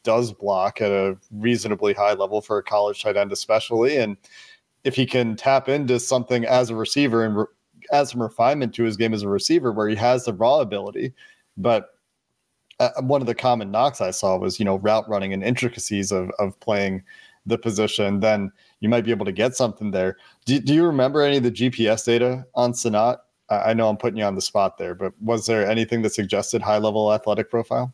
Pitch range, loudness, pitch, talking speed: 105-125 Hz, -22 LUFS, 115 Hz, 215 wpm